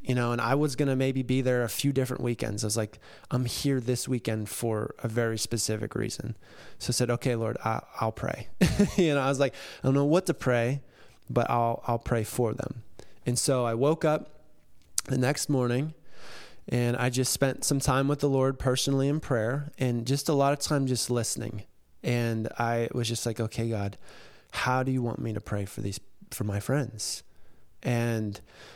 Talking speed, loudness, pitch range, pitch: 205 wpm, -28 LUFS, 115-135 Hz, 125 Hz